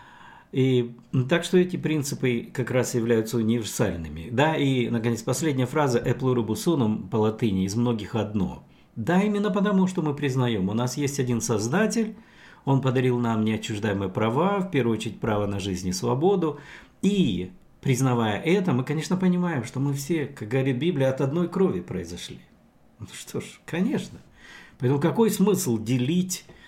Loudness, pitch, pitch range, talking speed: -25 LUFS, 130 Hz, 115-165 Hz, 155 wpm